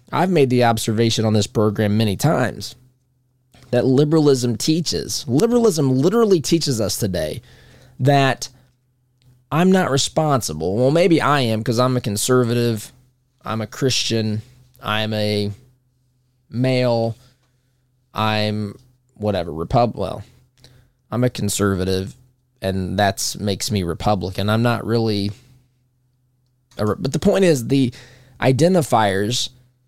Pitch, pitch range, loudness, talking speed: 125 Hz, 110-130 Hz, -19 LUFS, 115 wpm